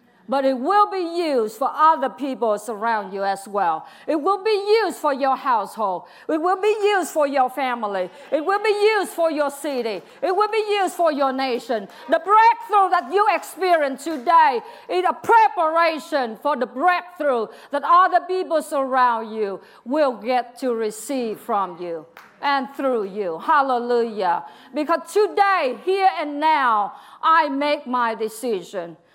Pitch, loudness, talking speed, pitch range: 290 Hz, -21 LUFS, 155 wpm, 240-360 Hz